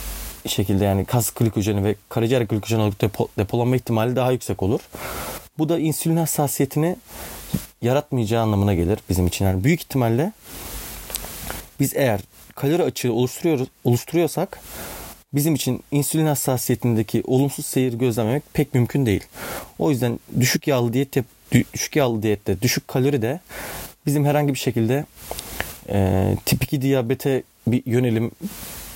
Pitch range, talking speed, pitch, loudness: 110-140 Hz, 130 wpm, 125 Hz, -22 LUFS